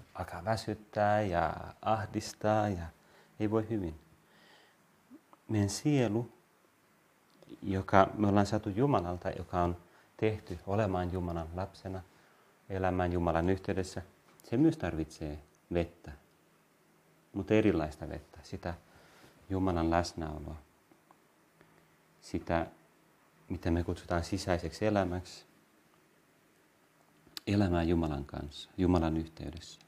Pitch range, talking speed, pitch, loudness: 85-105 Hz, 90 wpm, 90 Hz, -33 LUFS